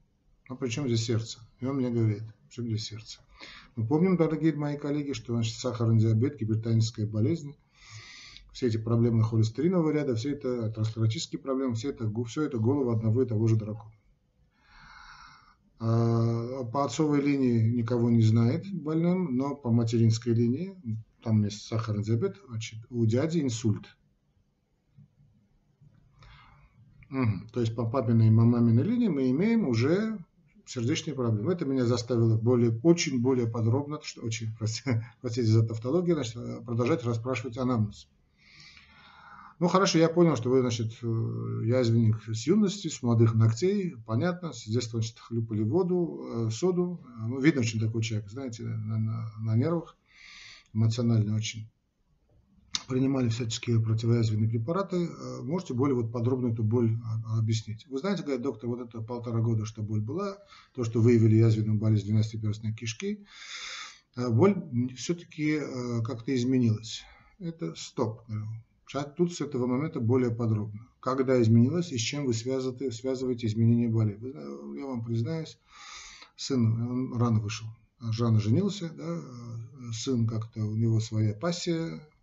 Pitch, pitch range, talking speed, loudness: 120 Hz, 115-140 Hz, 140 wpm, -28 LUFS